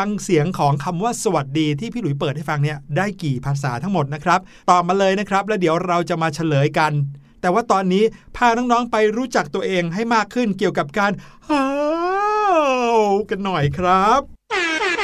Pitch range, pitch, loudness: 160-230 Hz, 190 Hz, -19 LUFS